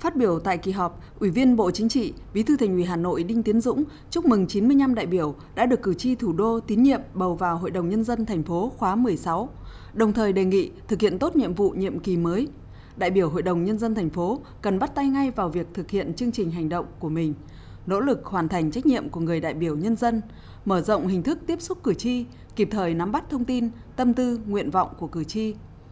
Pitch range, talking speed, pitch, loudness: 180-245 Hz, 250 wpm, 210 Hz, -24 LUFS